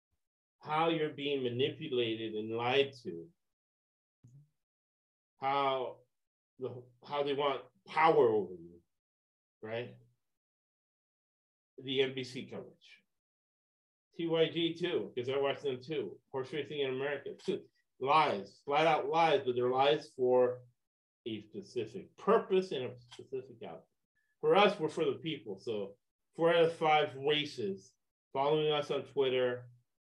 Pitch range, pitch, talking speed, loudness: 120-155 Hz, 135 Hz, 125 wpm, -33 LUFS